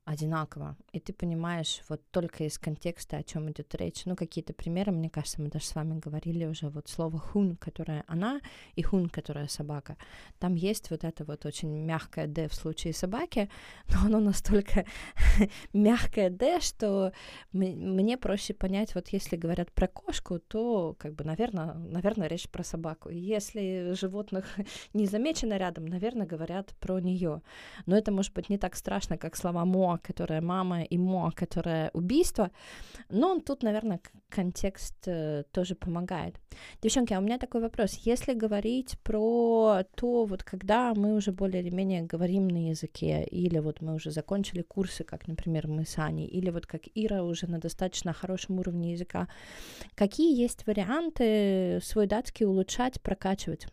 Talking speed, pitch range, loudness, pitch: 165 wpm, 165-210 Hz, -31 LUFS, 185 Hz